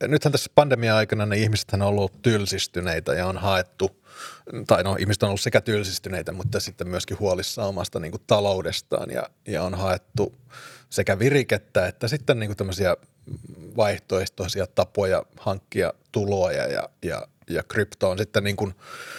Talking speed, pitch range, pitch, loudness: 145 wpm, 95-110 Hz, 100 Hz, -24 LUFS